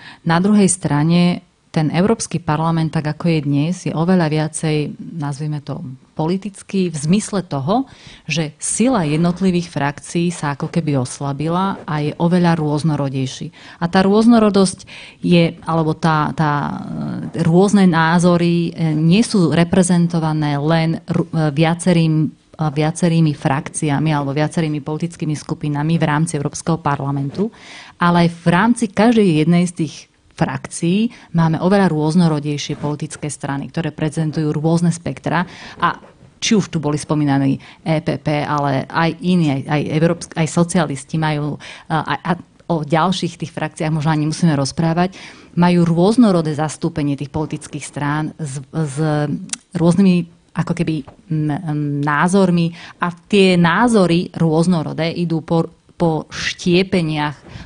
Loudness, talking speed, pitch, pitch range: -17 LUFS, 125 wpm, 160 Hz, 150-175 Hz